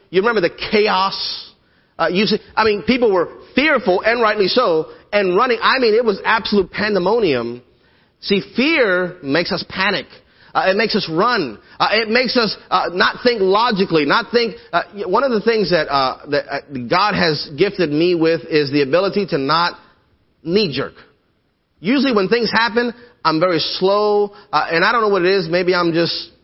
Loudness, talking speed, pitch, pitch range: -17 LUFS, 185 wpm, 195 Hz, 170-225 Hz